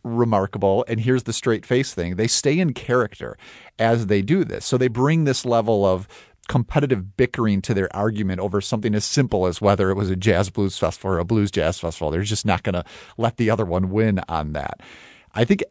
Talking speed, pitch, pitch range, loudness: 220 wpm, 105 Hz, 95-120 Hz, -21 LUFS